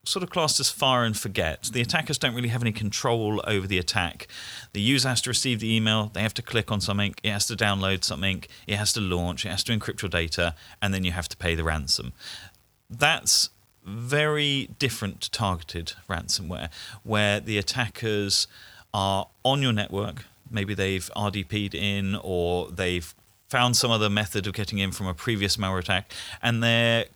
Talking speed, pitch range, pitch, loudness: 190 wpm, 95-115 Hz, 105 Hz, -25 LUFS